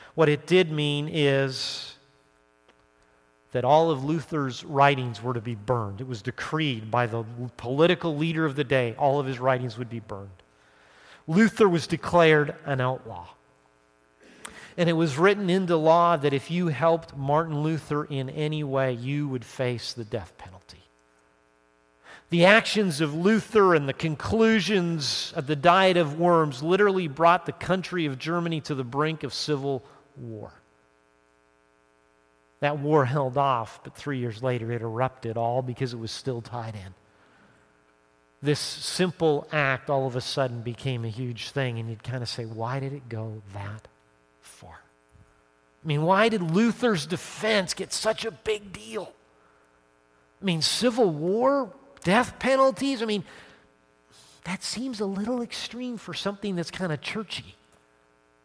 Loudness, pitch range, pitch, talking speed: -25 LUFS, 110-170 Hz, 135 Hz, 155 wpm